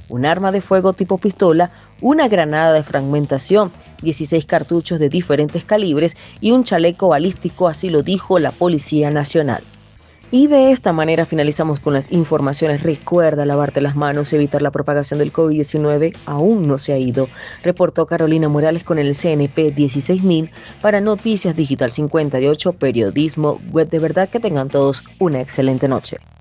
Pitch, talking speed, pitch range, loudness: 160 Hz, 155 wpm, 145-180 Hz, -16 LUFS